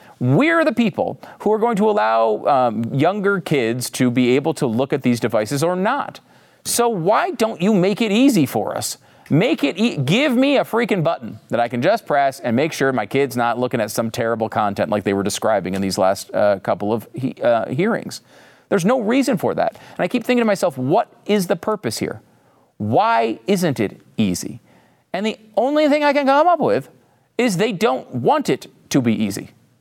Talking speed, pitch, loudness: 210 wpm, 185 Hz, -19 LUFS